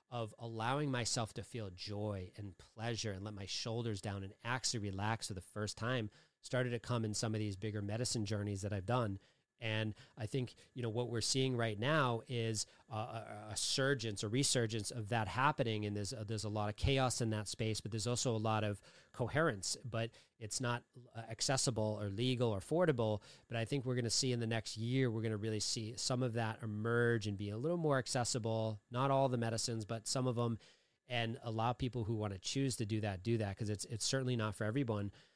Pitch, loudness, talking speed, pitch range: 115 Hz, -38 LUFS, 225 wpm, 105-125 Hz